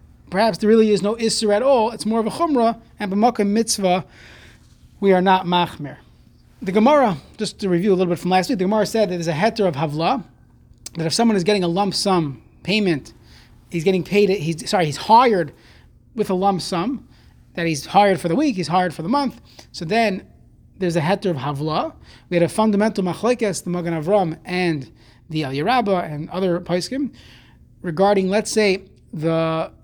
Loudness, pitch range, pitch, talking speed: -19 LUFS, 170-215 Hz, 190 Hz, 195 wpm